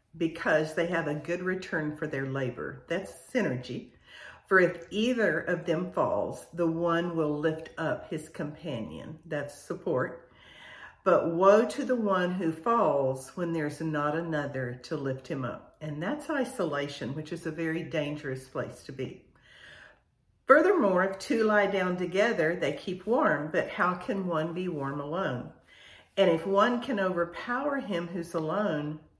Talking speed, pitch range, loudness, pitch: 155 wpm, 155-190 Hz, -29 LUFS, 170 Hz